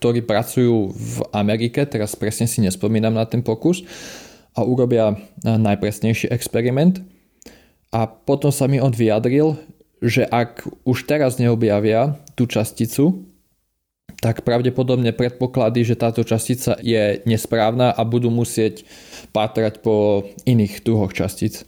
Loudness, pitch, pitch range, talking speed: -19 LUFS, 115 Hz, 110-125 Hz, 120 wpm